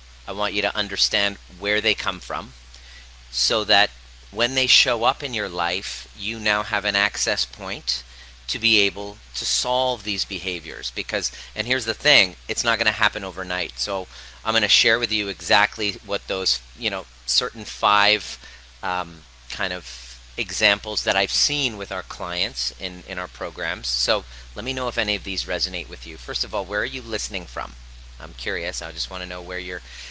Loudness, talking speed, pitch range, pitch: -22 LUFS, 195 wpm, 65-105 Hz, 100 Hz